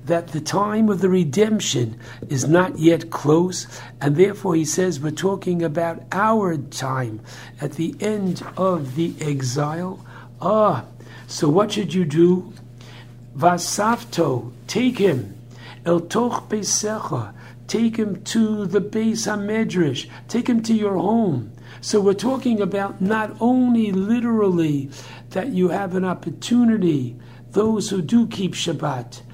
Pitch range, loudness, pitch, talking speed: 135-210 Hz, -21 LUFS, 175 Hz, 130 wpm